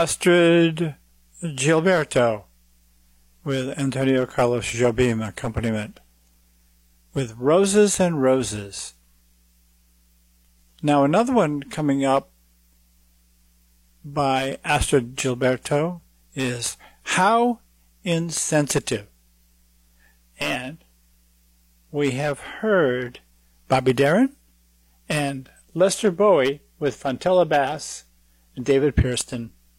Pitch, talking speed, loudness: 125 Hz, 75 wpm, -22 LUFS